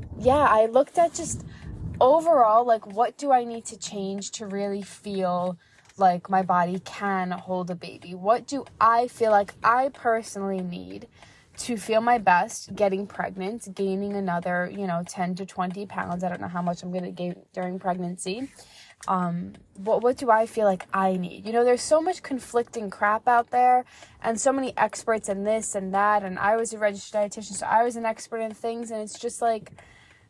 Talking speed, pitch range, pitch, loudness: 195 wpm, 185-230 Hz, 205 Hz, -25 LUFS